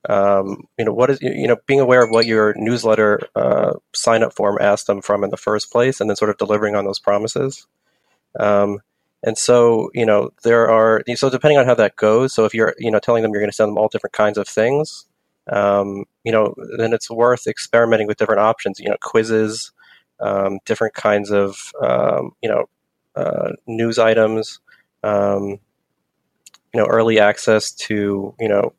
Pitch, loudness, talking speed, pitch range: 110 Hz, -17 LUFS, 195 wpm, 100-115 Hz